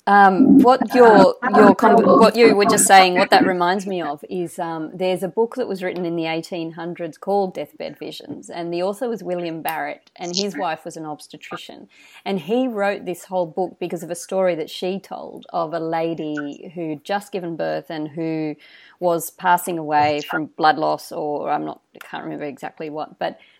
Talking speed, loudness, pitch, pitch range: 205 wpm, -18 LUFS, 180 Hz, 165-200 Hz